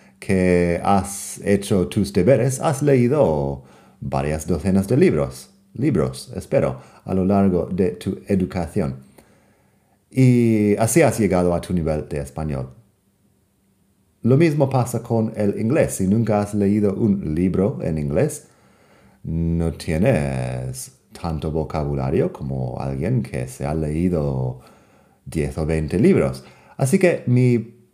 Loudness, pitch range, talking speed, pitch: -20 LUFS, 75-105 Hz, 125 wpm, 90 Hz